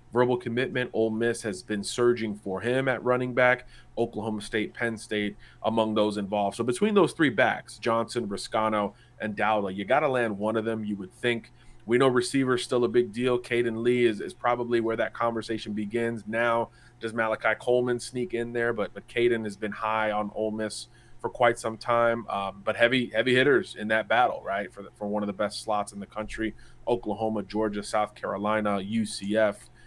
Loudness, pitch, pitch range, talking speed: -27 LUFS, 115 Hz, 105-120 Hz, 200 wpm